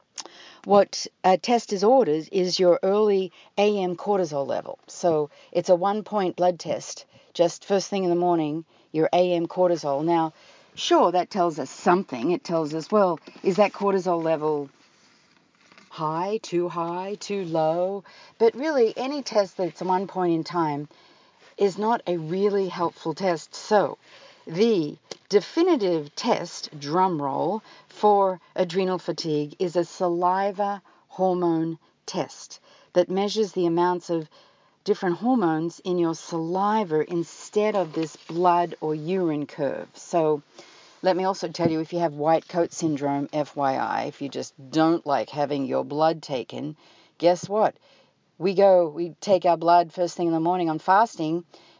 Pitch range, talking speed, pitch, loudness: 160-195 Hz, 150 wpm, 175 Hz, -24 LUFS